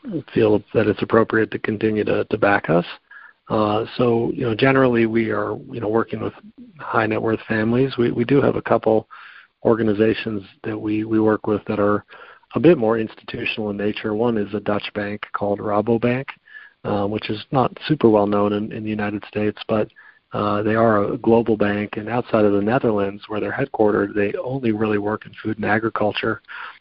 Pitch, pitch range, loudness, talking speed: 110 Hz, 105-115 Hz, -20 LUFS, 195 wpm